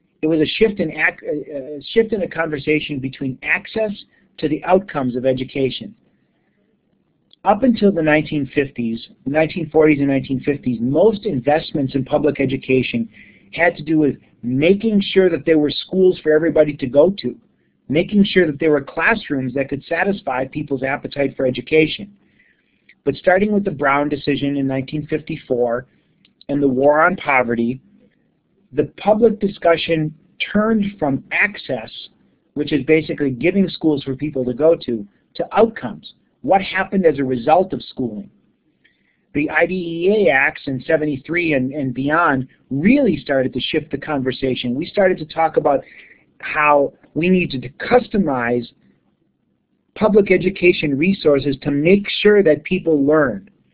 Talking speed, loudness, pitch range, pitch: 140 wpm, -18 LUFS, 135-180 Hz, 150 Hz